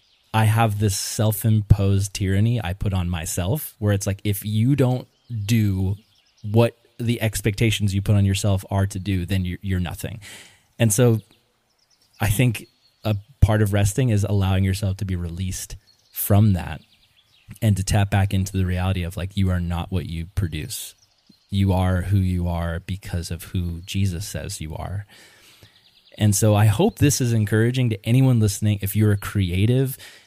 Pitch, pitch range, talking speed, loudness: 100 Hz, 95-110 Hz, 175 wpm, -22 LUFS